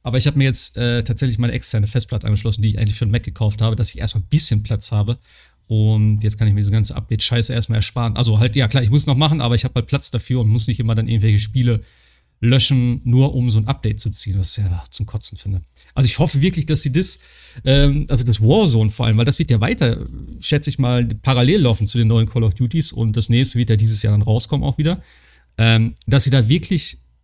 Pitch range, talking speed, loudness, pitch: 110-130 Hz, 260 wpm, -17 LUFS, 115 Hz